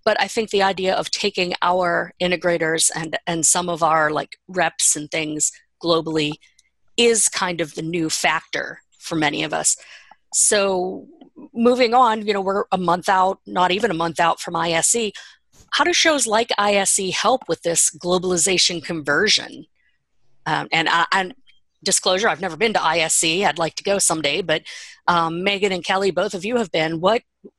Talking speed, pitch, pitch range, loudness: 175 wpm, 180 Hz, 165-205 Hz, -19 LUFS